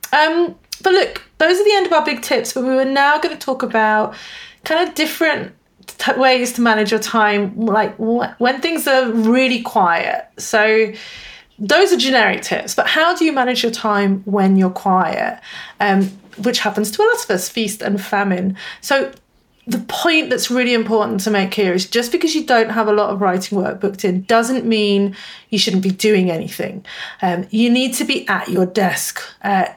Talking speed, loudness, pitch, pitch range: 200 wpm, -16 LUFS, 230 Hz, 205-280 Hz